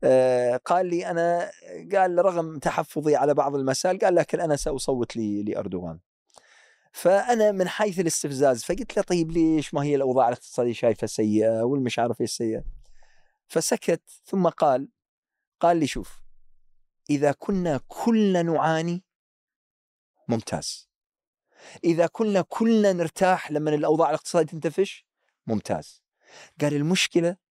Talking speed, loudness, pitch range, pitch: 120 wpm, -24 LUFS, 130-180 Hz, 160 Hz